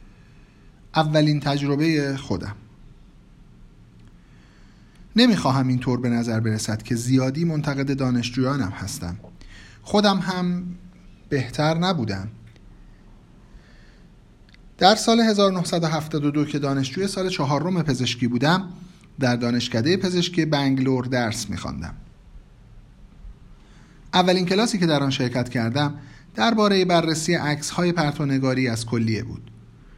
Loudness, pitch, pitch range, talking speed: -22 LUFS, 140 Hz, 120-175 Hz, 90 wpm